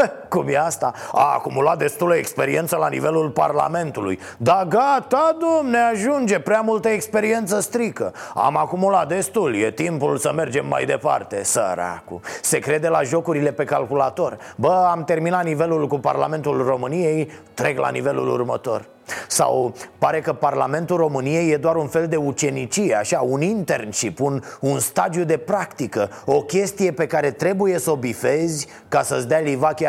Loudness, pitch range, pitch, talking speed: -20 LUFS, 145-190 Hz, 160 Hz, 155 wpm